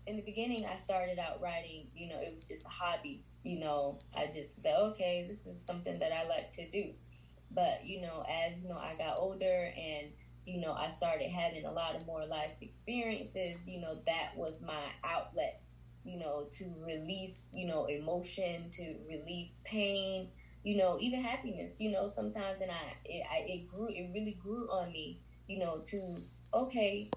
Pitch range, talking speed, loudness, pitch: 155-200 Hz, 190 wpm, -39 LUFS, 175 Hz